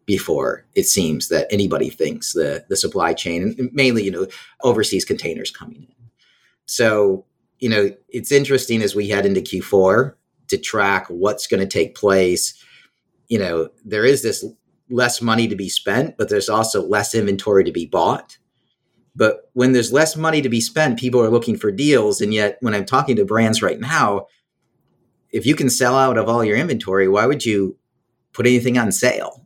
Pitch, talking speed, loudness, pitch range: 115 Hz, 185 wpm, -18 LUFS, 105-130 Hz